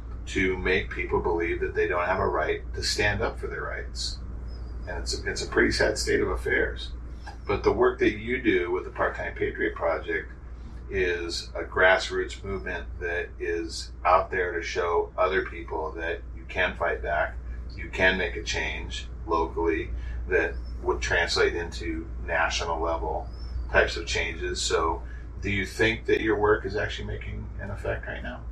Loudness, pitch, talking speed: -27 LUFS, 85 Hz, 175 wpm